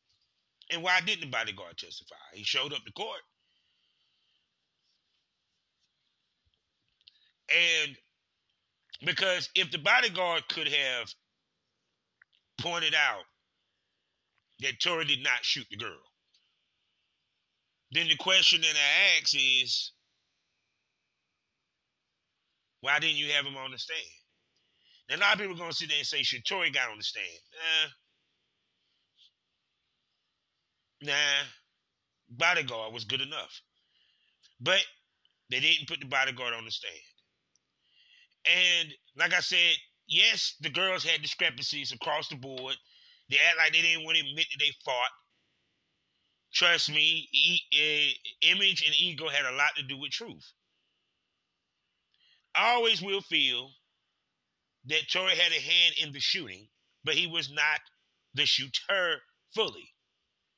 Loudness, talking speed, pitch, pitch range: -27 LUFS, 130 wpm, 160 Hz, 140-180 Hz